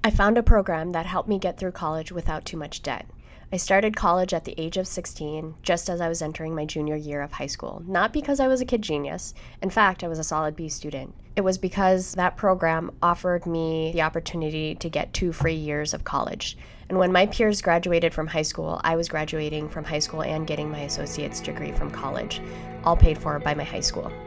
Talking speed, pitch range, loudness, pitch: 230 wpm, 155-185 Hz, -25 LUFS, 165 Hz